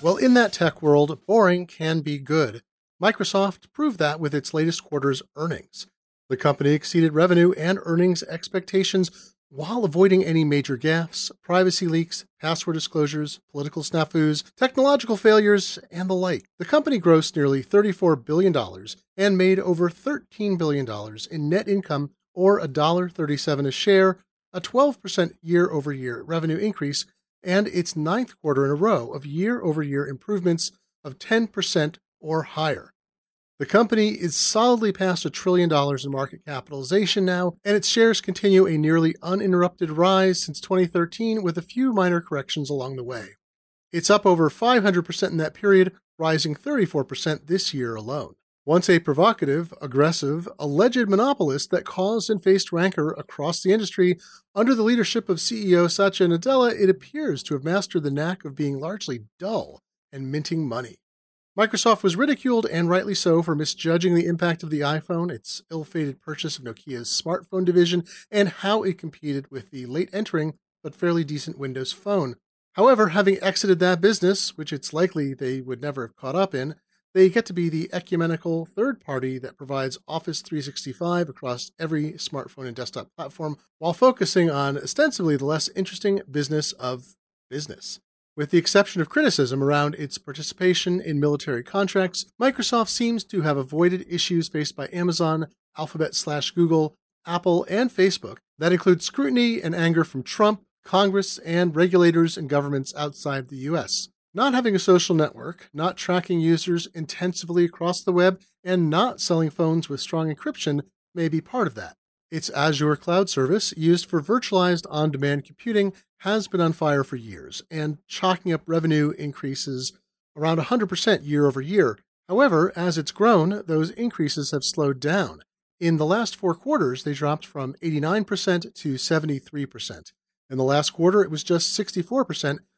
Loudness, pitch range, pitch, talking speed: -23 LUFS, 150-190 Hz, 170 Hz, 160 wpm